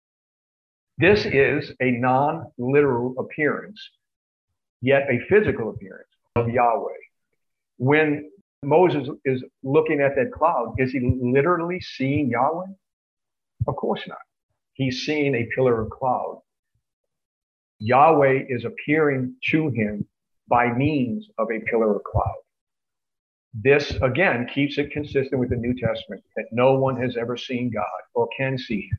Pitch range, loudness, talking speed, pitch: 125-150 Hz, -22 LUFS, 135 wpm, 135 Hz